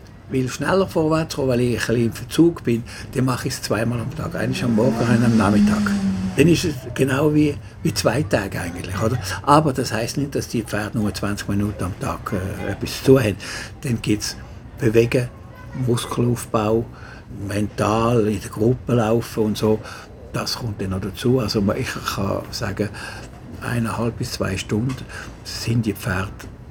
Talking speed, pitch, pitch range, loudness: 170 wpm, 115 Hz, 105-125 Hz, -21 LUFS